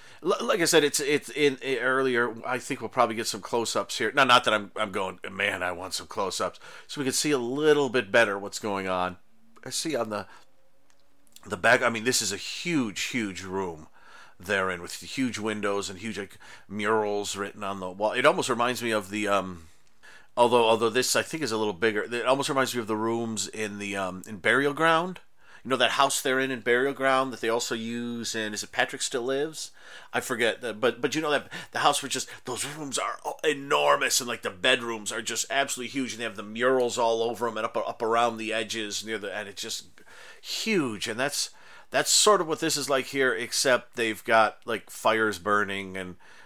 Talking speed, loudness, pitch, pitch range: 225 wpm, -26 LUFS, 115 Hz, 105-130 Hz